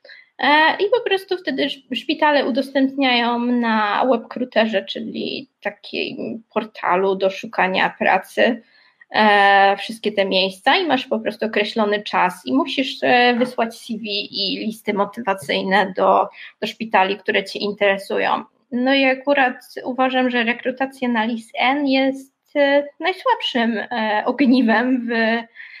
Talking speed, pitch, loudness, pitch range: 110 wpm, 245 Hz, -19 LUFS, 210-270 Hz